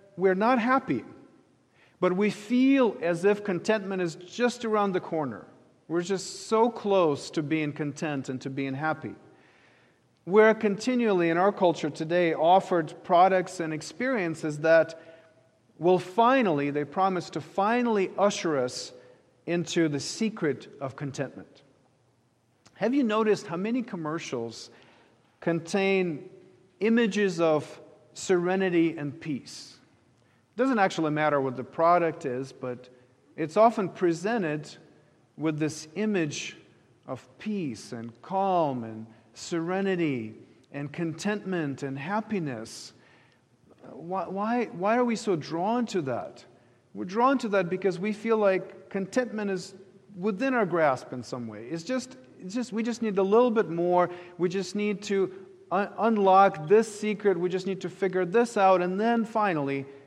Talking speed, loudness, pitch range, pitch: 140 wpm, -27 LUFS, 150-205 Hz, 180 Hz